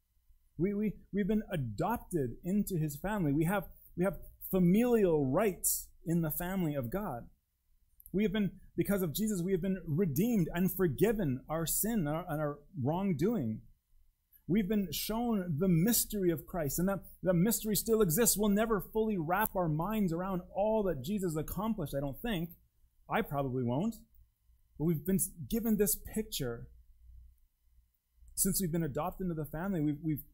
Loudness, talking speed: -33 LUFS, 165 wpm